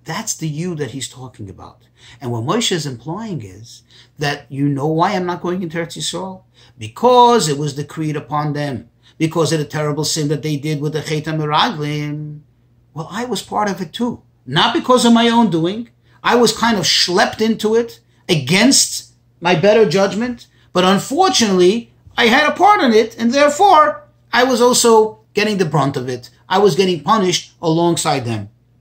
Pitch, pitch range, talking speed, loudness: 165 Hz, 140-220 Hz, 185 wpm, -15 LUFS